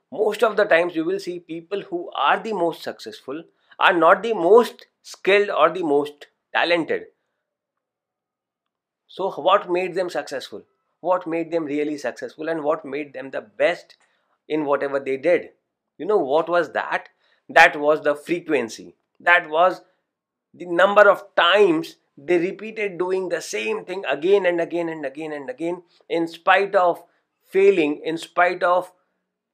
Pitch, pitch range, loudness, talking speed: 180 Hz, 160-210 Hz, -20 LUFS, 155 wpm